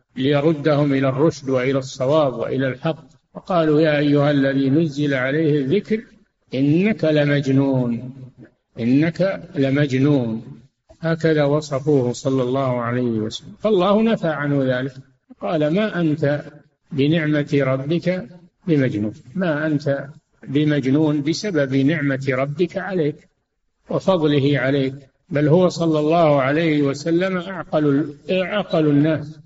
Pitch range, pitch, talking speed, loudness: 135-165 Hz, 145 Hz, 105 wpm, -19 LUFS